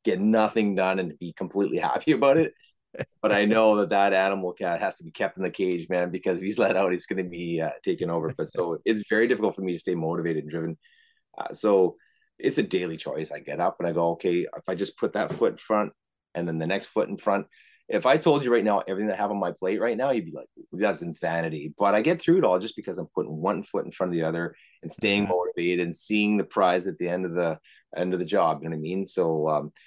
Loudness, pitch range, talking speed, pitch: -26 LUFS, 85-105 Hz, 275 wpm, 95 Hz